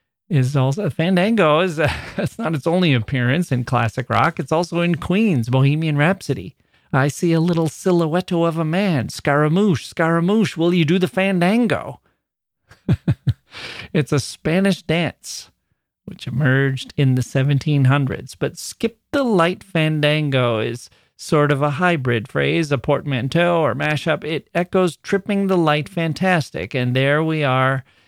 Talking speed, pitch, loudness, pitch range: 145 wpm, 155 Hz, -19 LUFS, 135-175 Hz